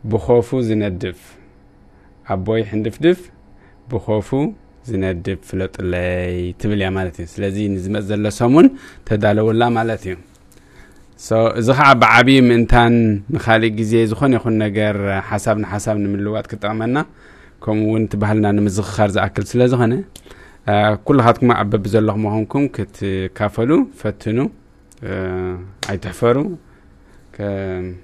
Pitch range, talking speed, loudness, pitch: 95-115 Hz, 95 wpm, -17 LUFS, 105 Hz